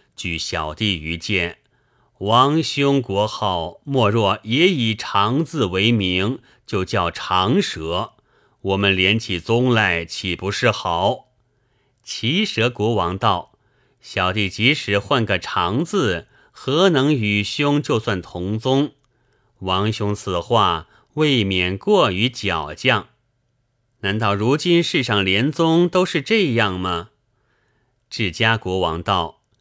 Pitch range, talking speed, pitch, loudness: 95-125 Hz, 160 characters per minute, 110 Hz, -19 LUFS